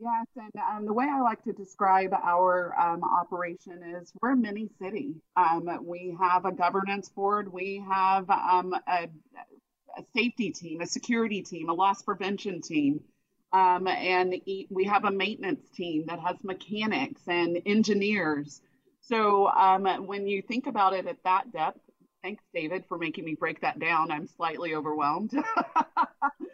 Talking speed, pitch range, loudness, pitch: 160 wpm, 175-210 Hz, -28 LUFS, 190 Hz